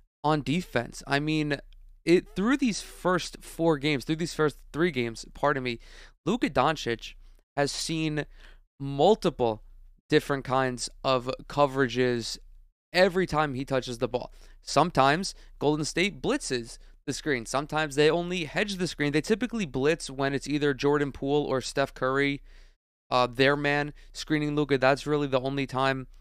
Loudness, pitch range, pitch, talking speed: -27 LUFS, 130-155 Hz, 145 Hz, 150 wpm